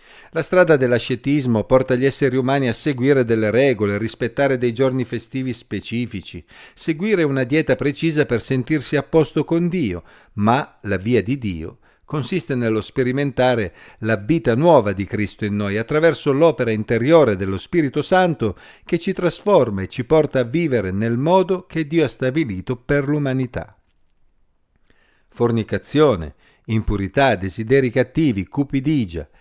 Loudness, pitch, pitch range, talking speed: -19 LUFS, 130 Hz, 110-150 Hz, 140 wpm